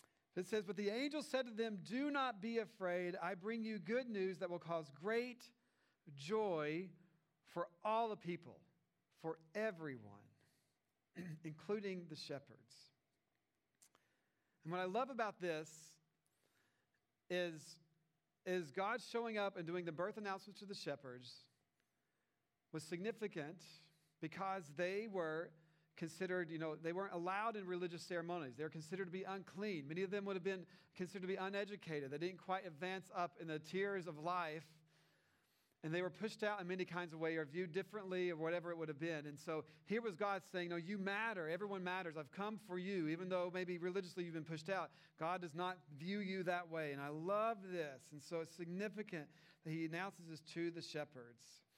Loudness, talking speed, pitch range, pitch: -45 LUFS, 180 wpm, 160-195 Hz, 175 Hz